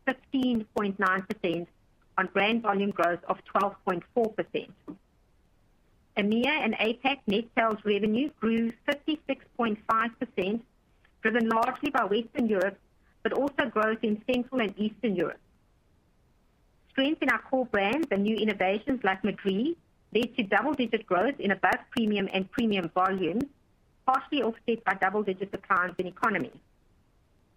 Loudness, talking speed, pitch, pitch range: -28 LUFS, 120 wpm, 220 Hz, 195-245 Hz